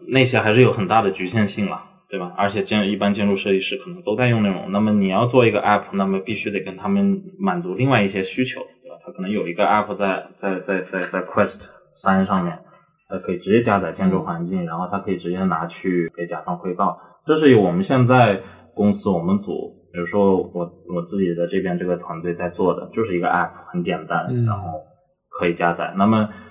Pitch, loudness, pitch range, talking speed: 100 Hz, -20 LUFS, 90-115 Hz, 345 characters per minute